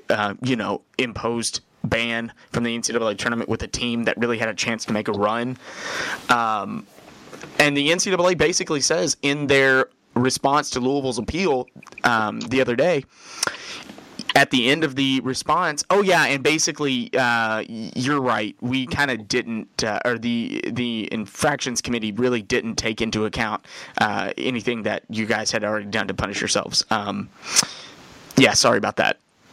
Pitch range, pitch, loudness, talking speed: 115-140 Hz, 125 Hz, -21 LUFS, 165 wpm